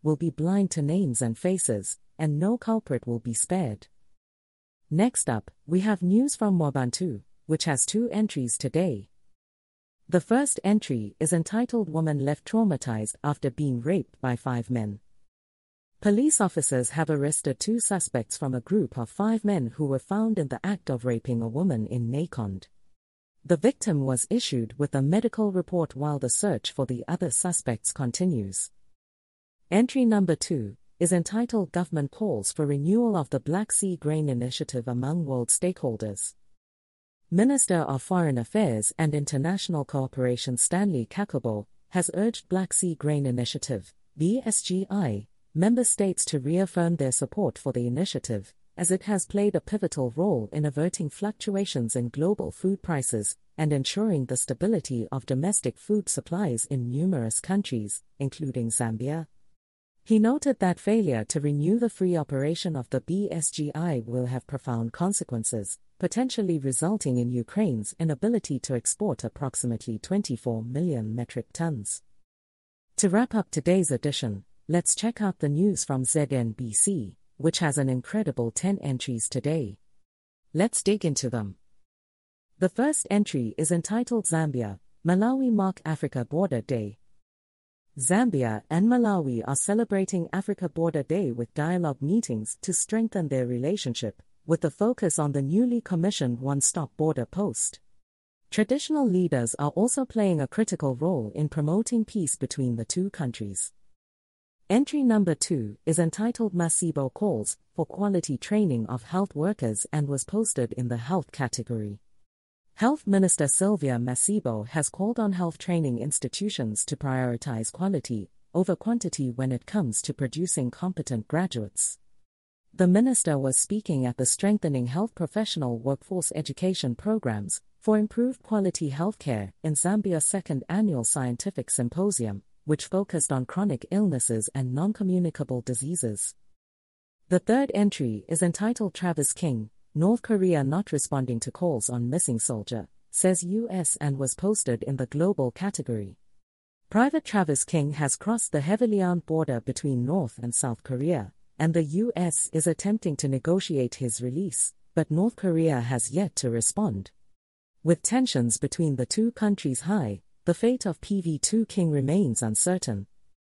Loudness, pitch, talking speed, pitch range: -26 LUFS, 150 Hz, 145 wpm, 125-190 Hz